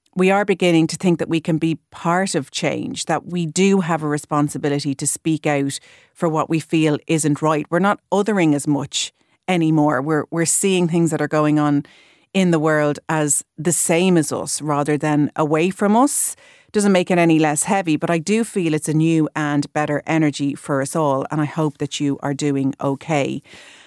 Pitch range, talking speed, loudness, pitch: 150-175 Hz, 205 wpm, -19 LUFS, 155 Hz